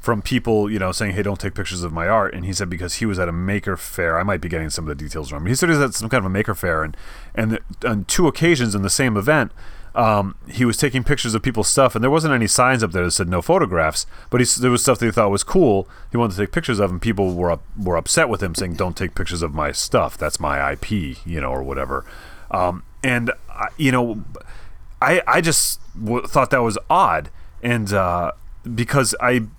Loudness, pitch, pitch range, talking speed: -20 LUFS, 100 Hz, 90-120 Hz, 255 wpm